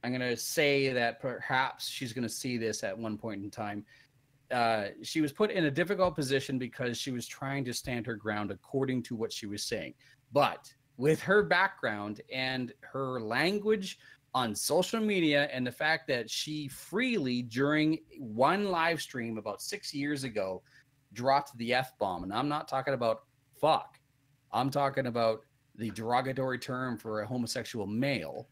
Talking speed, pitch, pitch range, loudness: 175 wpm, 130 Hz, 120-145 Hz, -32 LUFS